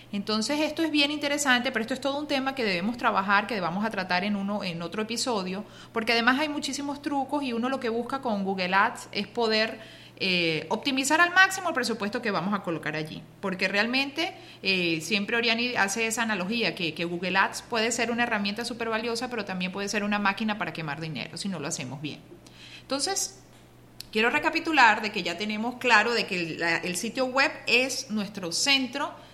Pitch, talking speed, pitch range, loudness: 225 Hz, 205 wpm, 195-260 Hz, -26 LUFS